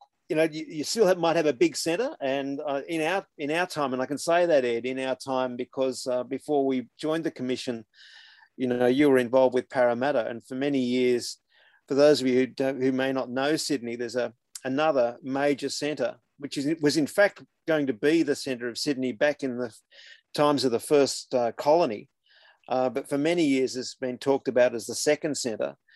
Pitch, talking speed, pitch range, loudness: 135 Hz, 215 wpm, 125-150 Hz, -26 LUFS